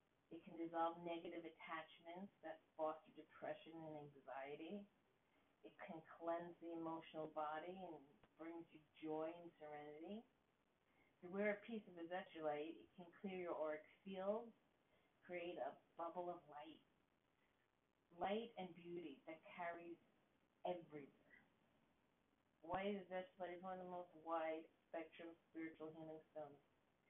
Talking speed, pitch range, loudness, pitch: 120 wpm, 155-180 Hz, -52 LUFS, 165 Hz